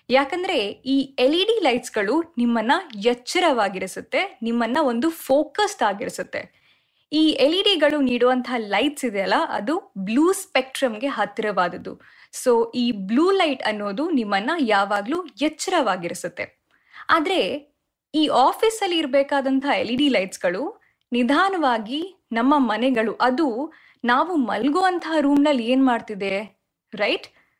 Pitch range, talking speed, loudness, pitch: 235-310 Hz, 115 wpm, -21 LUFS, 270 Hz